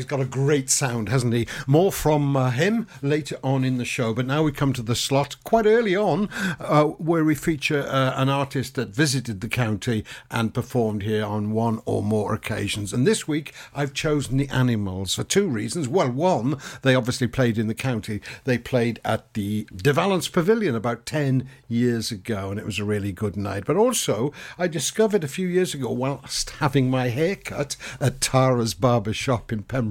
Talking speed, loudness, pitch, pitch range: 200 wpm, -23 LUFS, 130 Hz, 115-150 Hz